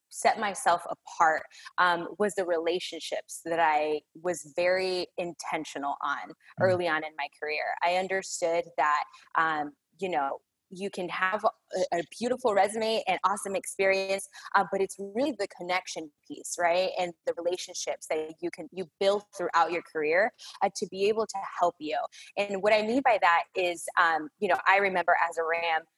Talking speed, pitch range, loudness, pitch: 175 wpm, 165-195 Hz, -28 LUFS, 180 Hz